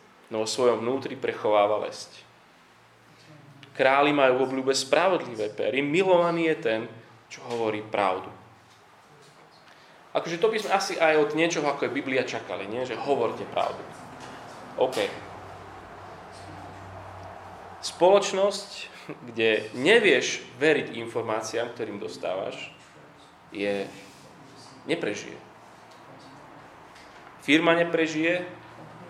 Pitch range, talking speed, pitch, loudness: 110-165 Hz, 95 wpm, 135 Hz, -25 LUFS